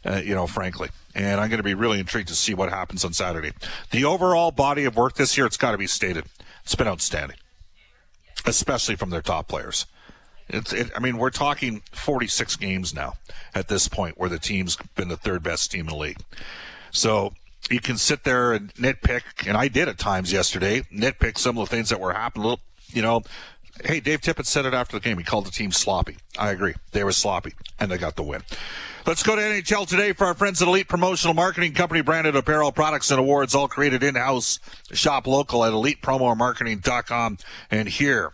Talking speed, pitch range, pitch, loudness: 205 wpm, 95-140 Hz, 115 Hz, -23 LUFS